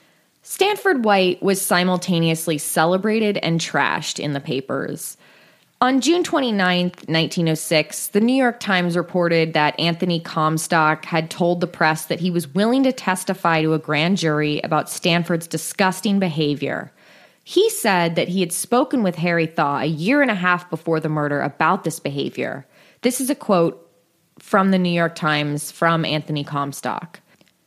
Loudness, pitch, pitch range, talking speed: -20 LUFS, 170 Hz, 160-195 Hz, 155 wpm